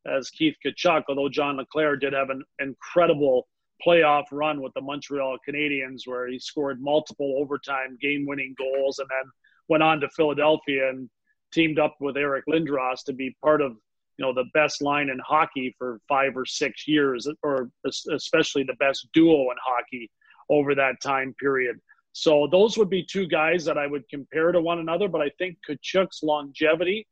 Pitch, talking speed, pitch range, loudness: 145 Hz, 175 wpm, 135-155 Hz, -24 LUFS